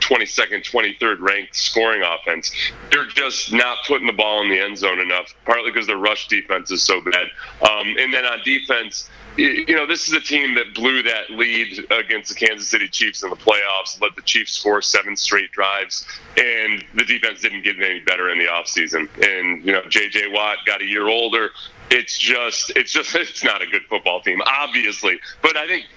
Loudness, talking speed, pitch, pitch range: -18 LUFS, 200 wpm, 110 Hz, 105-120 Hz